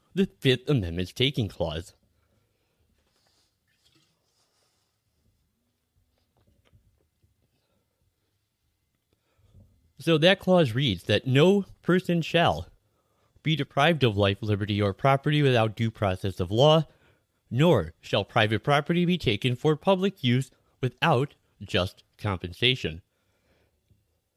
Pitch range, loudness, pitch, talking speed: 95-140 Hz, -25 LUFS, 110 Hz, 90 wpm